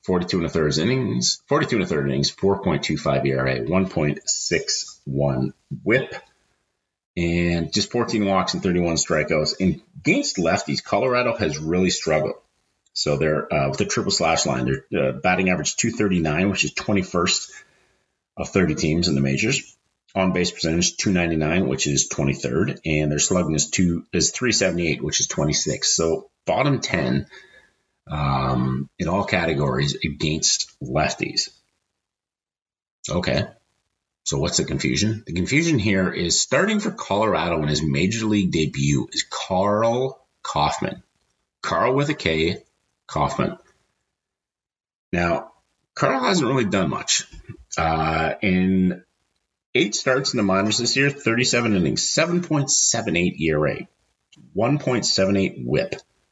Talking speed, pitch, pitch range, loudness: 140 wpm, 90 Hz, 75-105 Hz, -21 LUFS